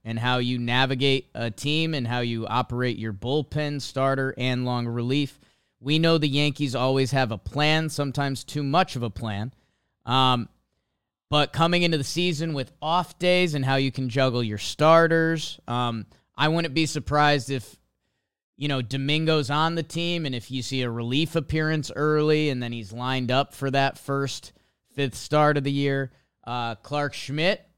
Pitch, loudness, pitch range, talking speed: 135 Hz, -24 LUFS, 125-150 Hz, 175 wpm